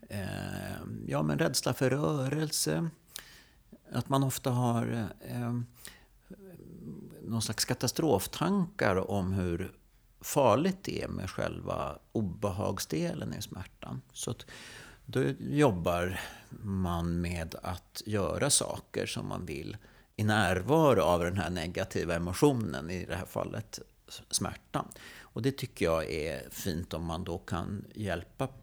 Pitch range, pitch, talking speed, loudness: 90-130 Hz, 105 Hz, 120 wpm, -32 LUFS